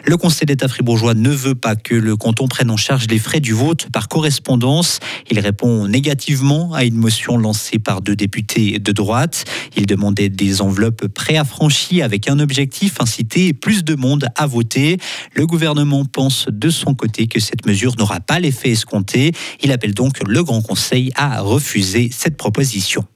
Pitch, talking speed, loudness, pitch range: 125 Hz, 175 wpm, -15 LUFS, 110-145 Hz